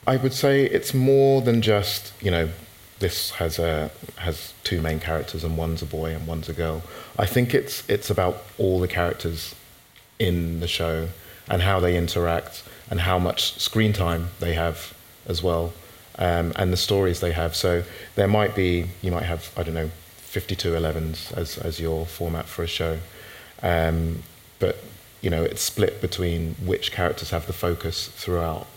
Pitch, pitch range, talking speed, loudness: 85 Hz, 85-95 Hz, 180 wpm, -24 LUFS